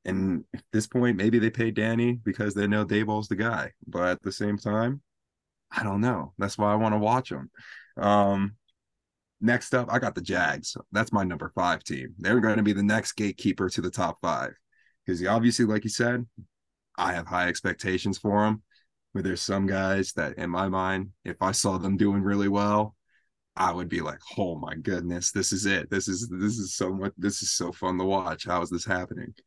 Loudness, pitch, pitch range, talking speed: -27 LUFS, 100 Hz, 95-110 Hz, 210 wpm